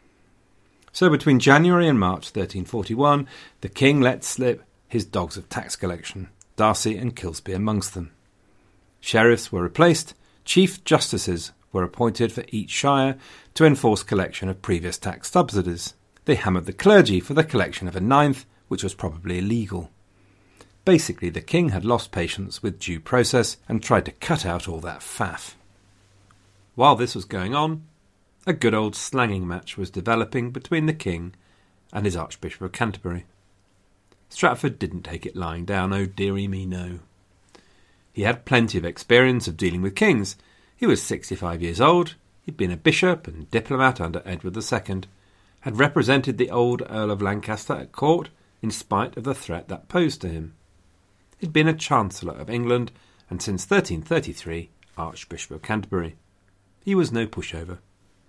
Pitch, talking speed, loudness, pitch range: 100 Hz, 160 wpm, -22 LUFS, 95-125 Hz